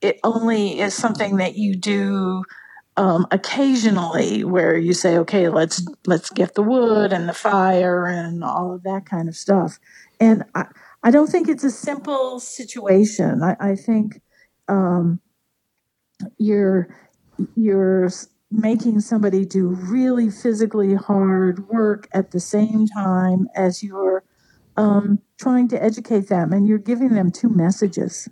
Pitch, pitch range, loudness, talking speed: 200 Hz, 185-225 Hz, -19 LUFS, 140 wpm